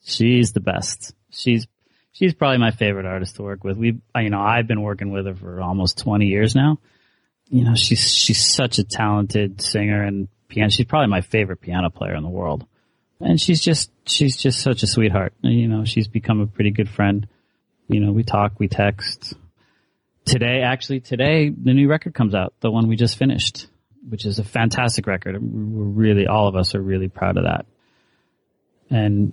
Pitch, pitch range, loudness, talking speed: 110 Hz, 100-120 Hz, -19 LUFS, 195 wpm